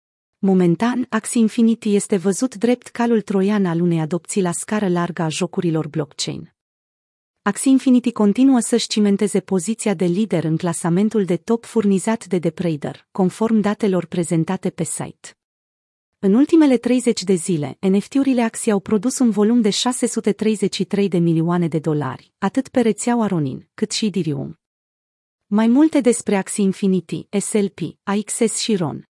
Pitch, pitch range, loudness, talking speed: 200 Hz, 175-225 Hz, -19 LUFS, 145 wpm